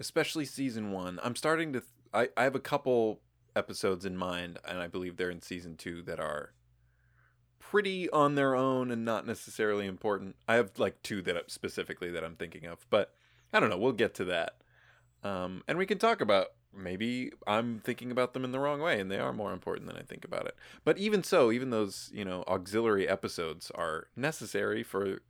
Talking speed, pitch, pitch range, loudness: 210 wpm, 115 Hz, 95-130 Hz, -33 LUFS